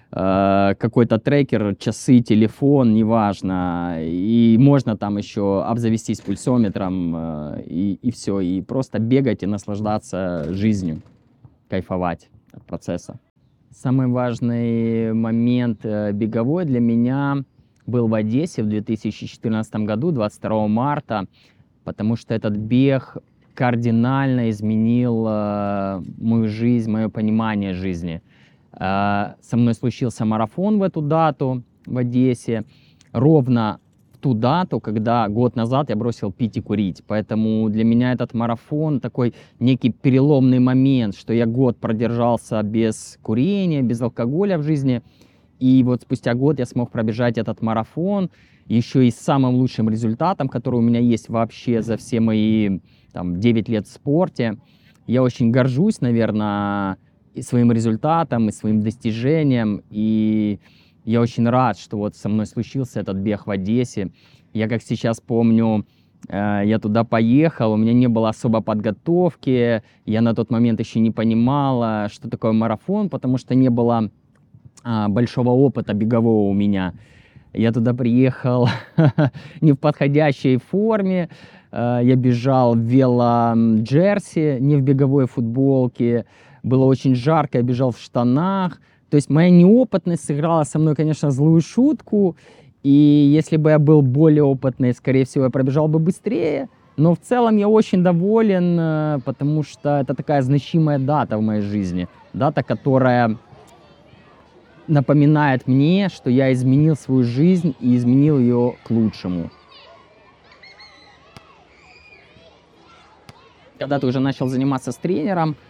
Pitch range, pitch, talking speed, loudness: 110-140 Hz, 120 Hz, 130 wpm, -19 LUFS